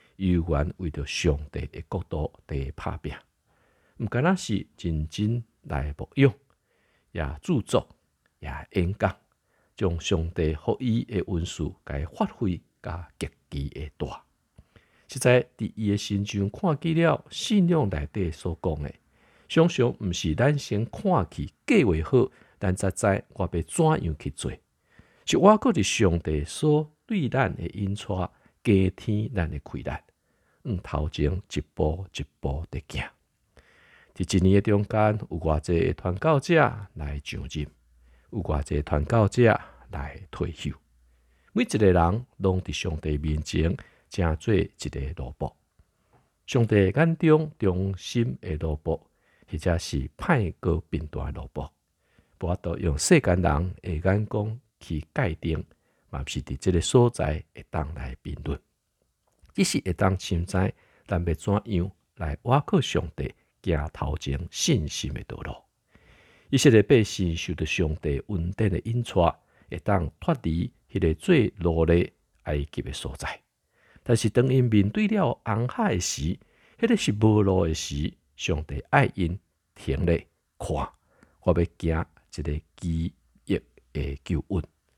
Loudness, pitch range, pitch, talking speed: -26 LUFS, 75-105 Hz, 90 Hz, 195 characters per minute